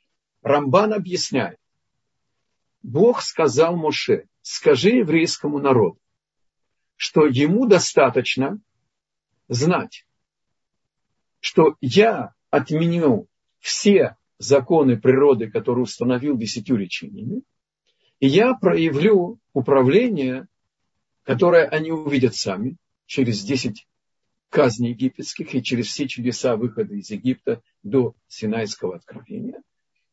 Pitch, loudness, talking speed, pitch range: 140 Hz, -20 LUFS, 90 wpm, 130-175 Hz